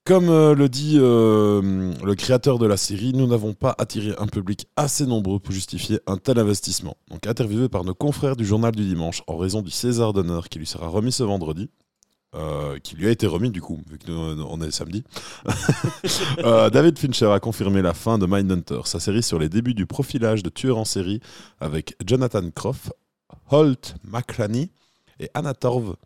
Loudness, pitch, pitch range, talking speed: -21 LUFS, 105 Hz, 95-125 Hz, 190 wpm